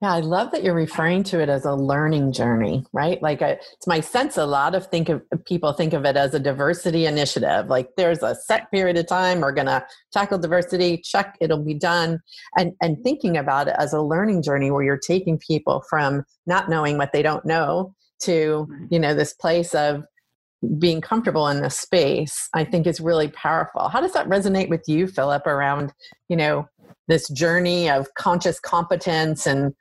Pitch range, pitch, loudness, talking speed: 145-175 Hz, 165 Hz, -21 LUFS, 195 wpm